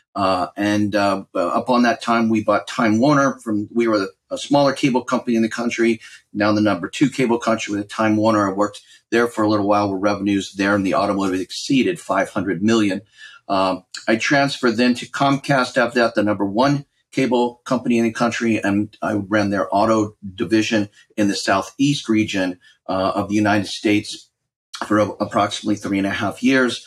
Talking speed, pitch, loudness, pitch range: 195 wpm, 110 Hz, -19 LUFS, 100-120 Hz